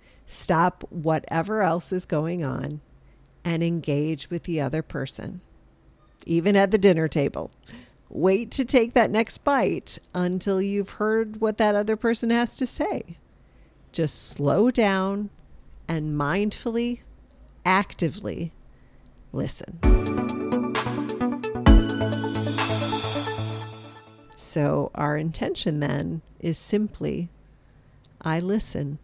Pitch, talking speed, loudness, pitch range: 165 Hz, 100 wpm, -24 LUFS, 140-205 Hz